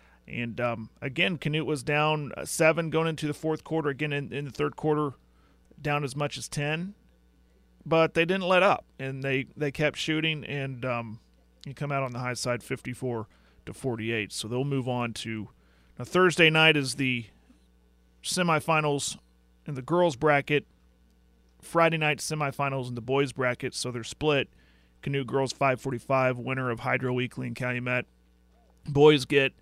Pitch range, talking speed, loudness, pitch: 115-150 Hz, 165 wpm, -27 LUFS, 135 Hz